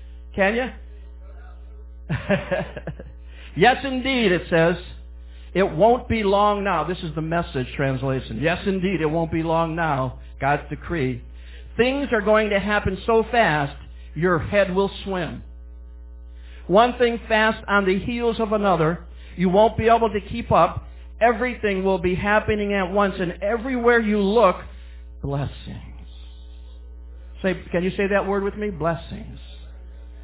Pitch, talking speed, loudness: 170 Hz, 140 wpm, -21 LUFS